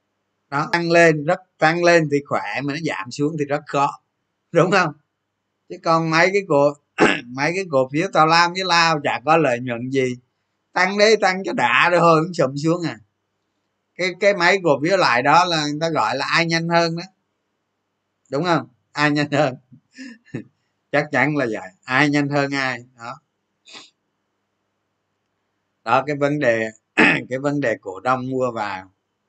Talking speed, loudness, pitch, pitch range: 175 wpm, -19 LUFS, 145 Hz, 110-165 Hz